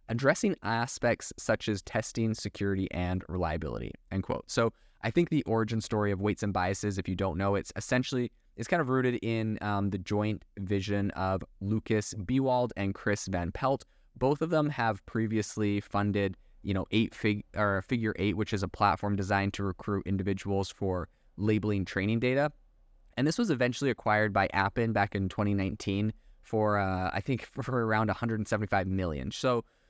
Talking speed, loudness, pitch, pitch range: 175 wpm, -31 LUFS, 105 Hz, 95-115 Hz